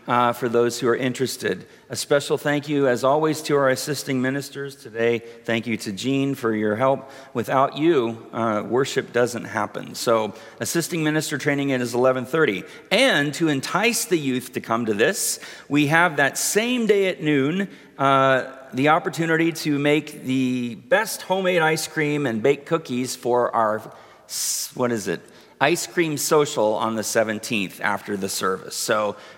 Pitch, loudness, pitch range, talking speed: 135 Hz, -22 LUFS, 120-150 Hz, 165 wpm